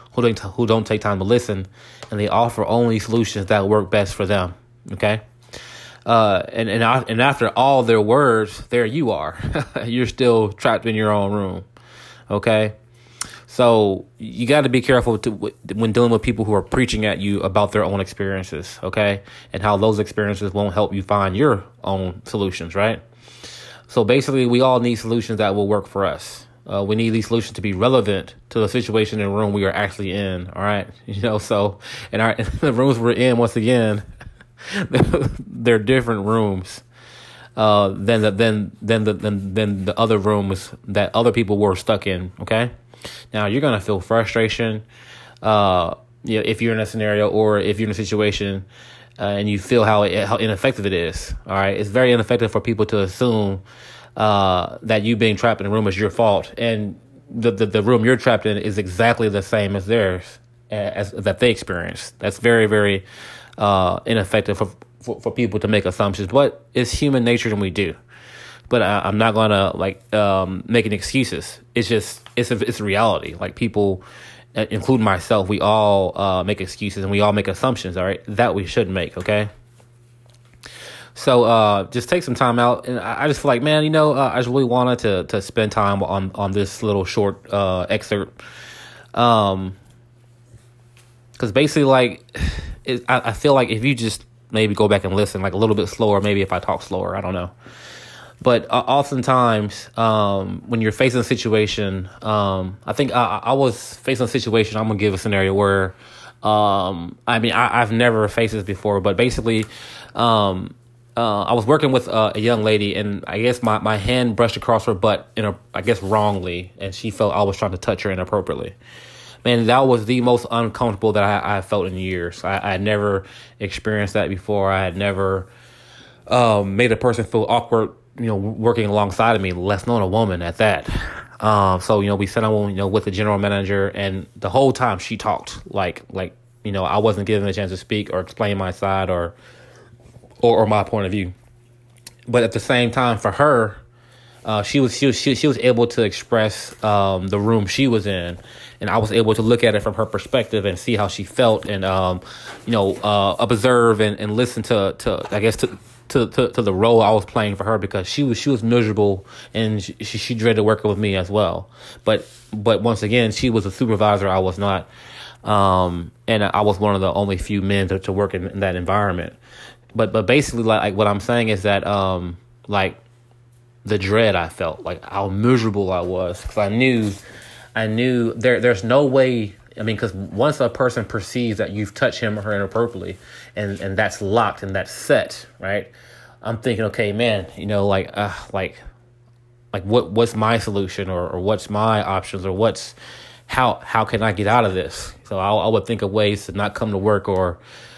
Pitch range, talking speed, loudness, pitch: 100-120 Hz, 205 wpm, -19 LUFS, 110 Hz